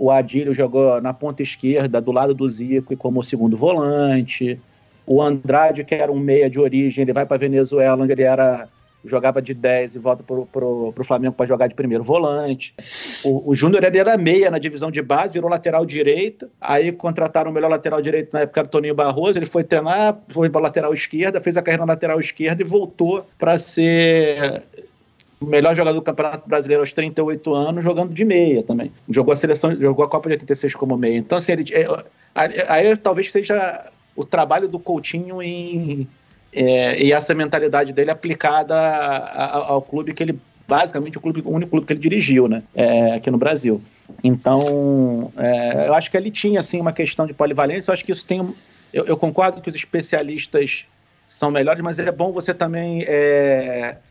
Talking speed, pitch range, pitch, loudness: 200 wpm, 135-170 Hz, 150 Hz, -18 LUFS